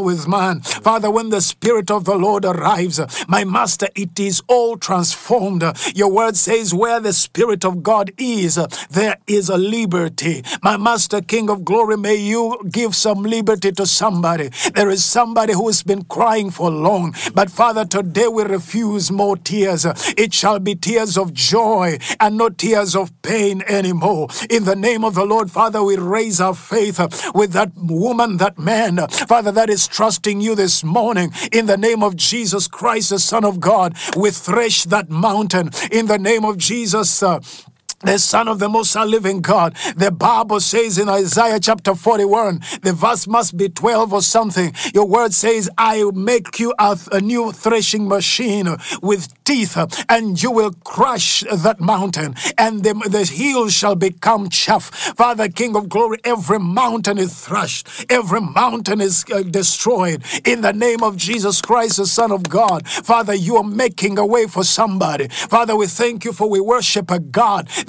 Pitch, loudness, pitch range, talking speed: 205 Hz, -15 LUFS, 190-225 Hz, 175 wpm